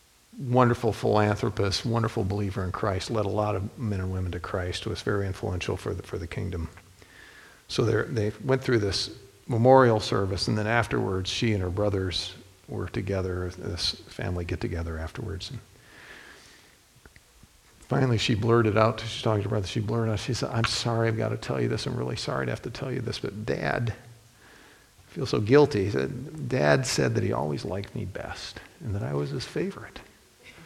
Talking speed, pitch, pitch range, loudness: 190 wpm, 105 Hz, 95-115 Hz, -27 LUFS